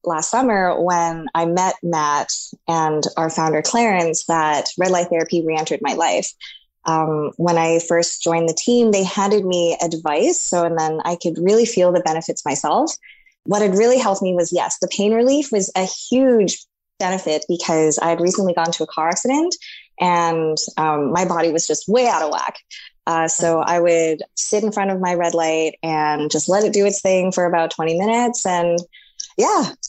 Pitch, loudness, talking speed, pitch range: 175 Hz, -18 LUFS, 190 wpm, 165-200 Hz